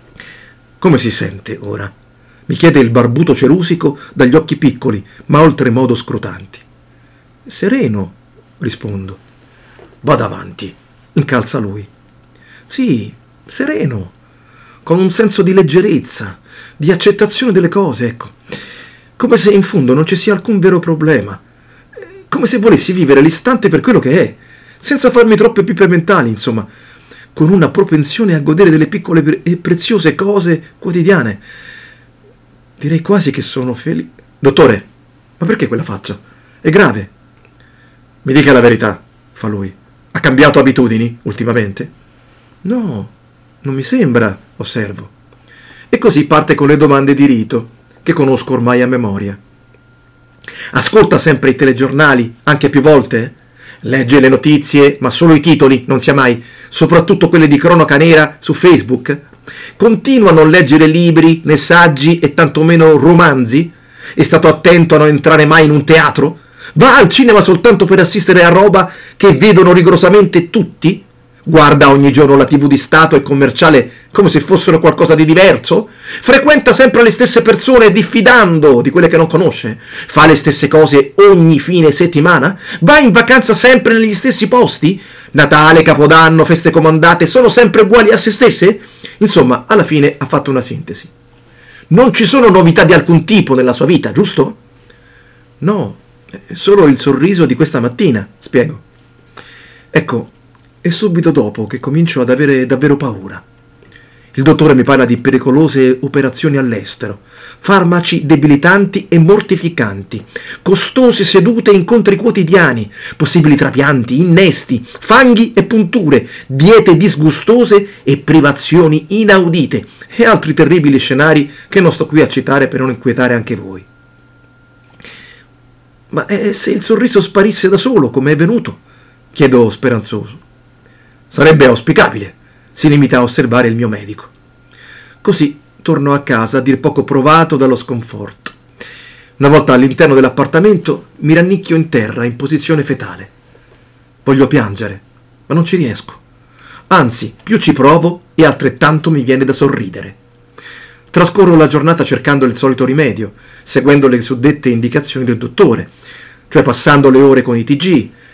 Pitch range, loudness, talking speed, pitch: 130-180 Hz, -9 LUFS, 140 wpm, 150 Hz